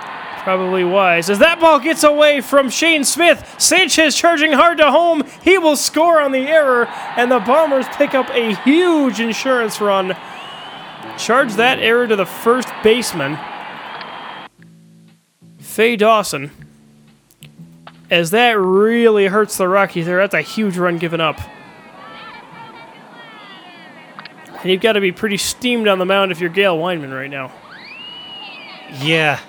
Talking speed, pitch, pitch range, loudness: 140 wpm, 215 Hz, 175-270 Hz, -14 LUFS